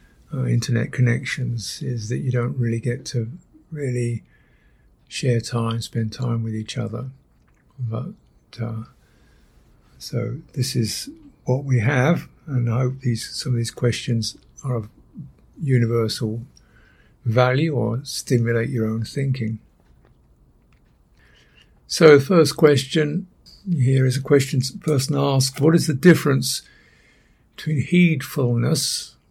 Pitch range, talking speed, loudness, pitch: 115-145 Hz, 125 wpm, -21 LUFS, 125 Hz